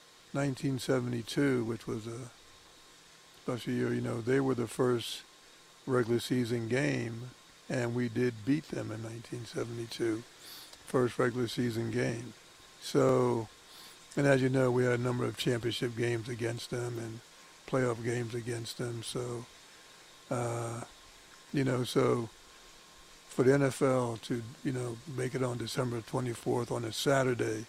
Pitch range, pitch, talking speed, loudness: 115-130 Hz, 120 Hz, 140 wpm, -33 LUFS